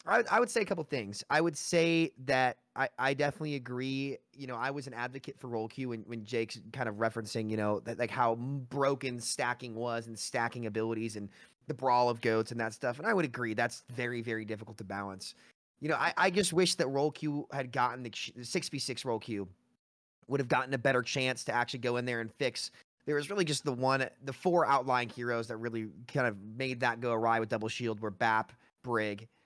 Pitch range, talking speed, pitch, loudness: 115-140 Hz, 225 wpm, 125 Hz, -33 LUFS